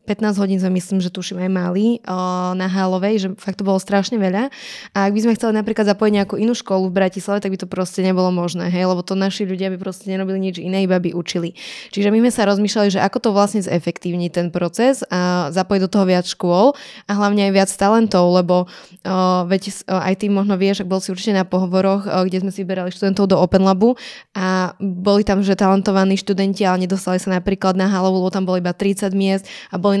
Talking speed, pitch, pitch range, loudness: 225 wpm, 195 Hz, 185-200 Hz, -18 LUFS